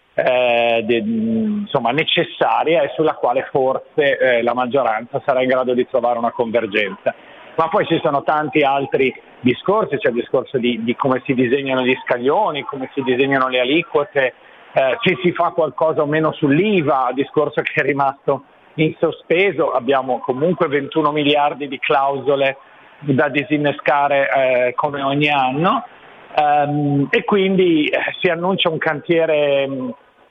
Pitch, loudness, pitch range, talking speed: 145 Hz, -17 LUFS, 130-160 Hz, 145 wpm